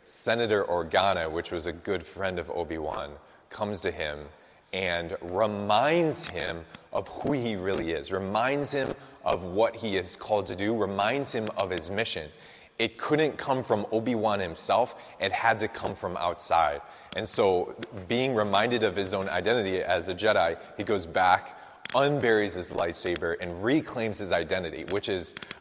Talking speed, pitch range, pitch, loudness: 165 wpm, 90-125 Hz, 105 Hz, -28 LUFS